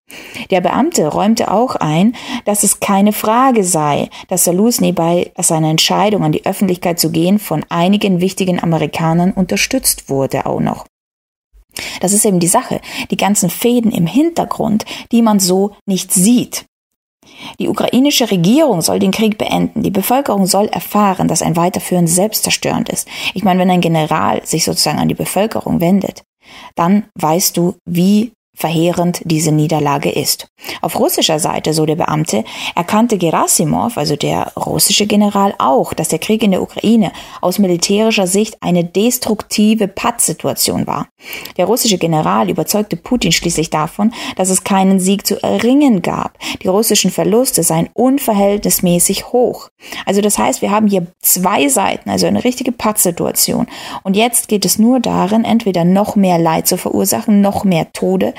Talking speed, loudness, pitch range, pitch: 155 wpm, -13 LUFS, 175-220 Hz, 195 Hz